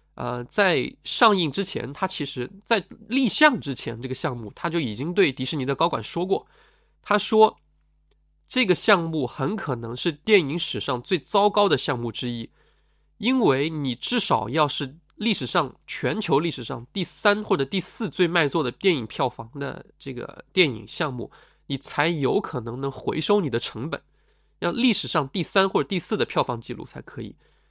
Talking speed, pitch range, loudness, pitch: 260 characters per minute, 135-205 Hz, -24 LUFS, 165 Hz